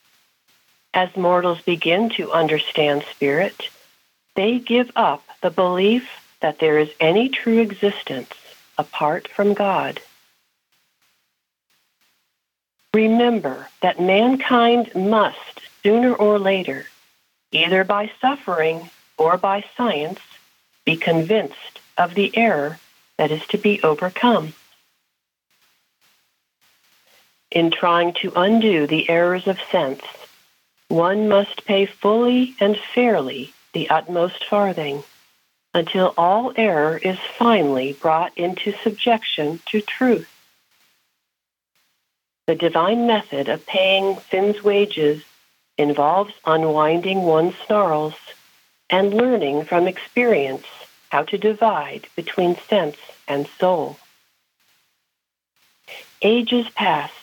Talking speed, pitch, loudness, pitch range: 100 wpm, 190 Hz, -19 LUFS, 160-215 Hz